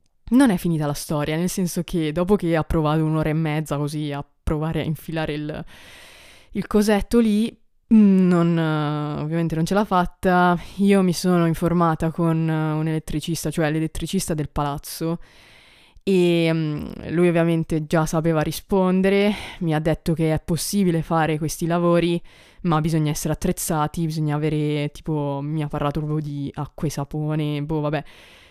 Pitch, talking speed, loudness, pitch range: 160 Hz, 155 wpm, -22 LUFS, 150-175 Hz